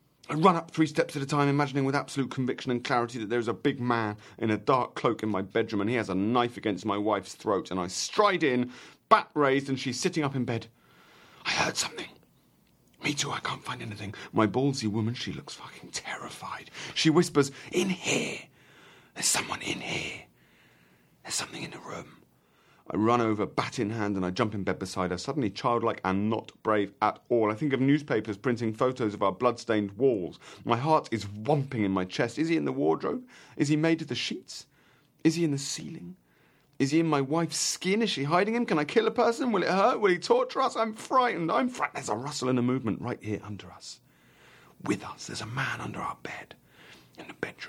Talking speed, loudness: 220 wpm, -28 LUFS